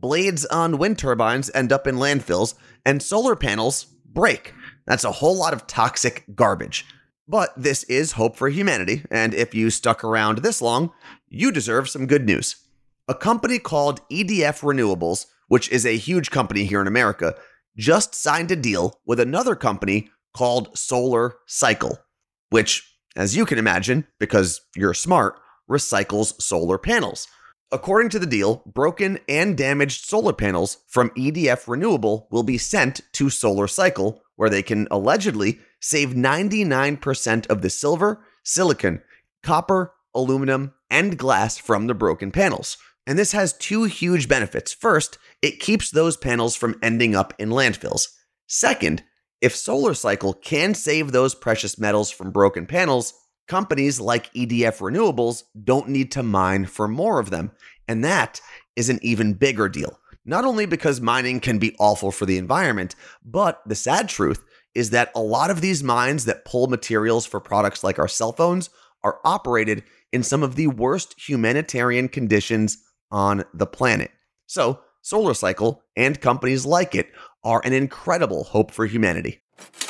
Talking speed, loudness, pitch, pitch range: 155 wpm, -21 LUFS, 125 Hz, 110-145 Hz